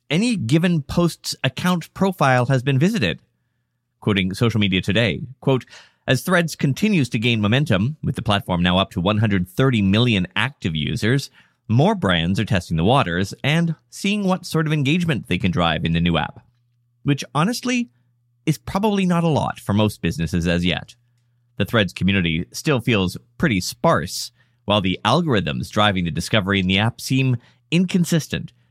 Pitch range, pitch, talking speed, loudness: 100-155 Hz, 120 Hz, 165 wpm, -20 LUFS